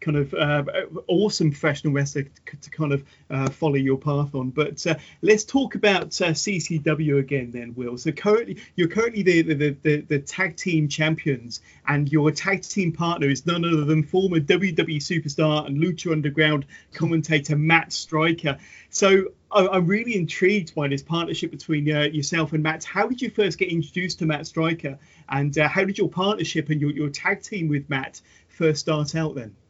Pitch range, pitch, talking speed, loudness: 145-175 Hz, 155 Hz, 185 wpm, -23 LUFS